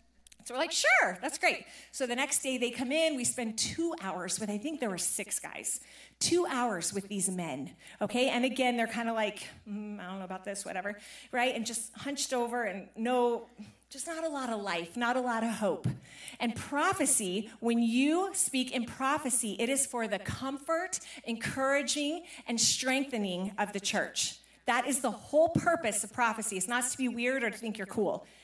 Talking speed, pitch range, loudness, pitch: 205 wpm, 210-270 Hz, -31 LUFS, 240 Hz